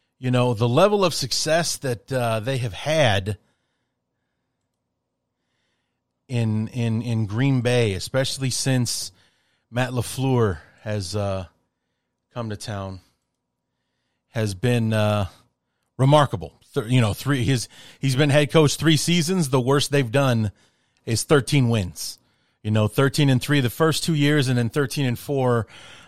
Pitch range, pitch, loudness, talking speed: 110-140 Hz, 125 Hz, -22 LUFS, 140 wpm